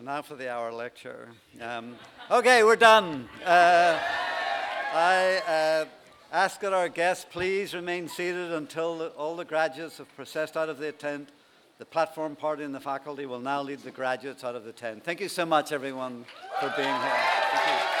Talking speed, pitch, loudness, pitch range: 185 wpm, 155 Hz, -26 LUFS, 135-175 Hz